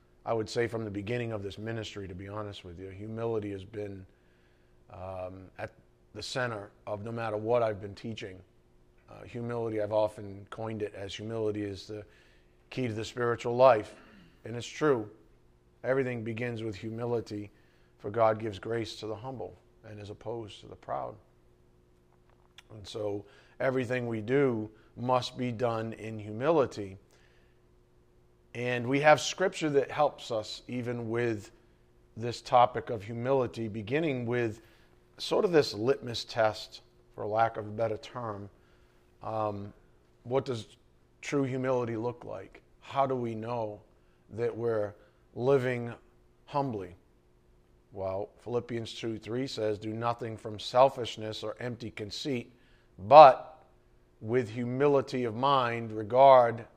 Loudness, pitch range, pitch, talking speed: -30 LUFS, 90-120 Hz, 110 Hz, 140 wpm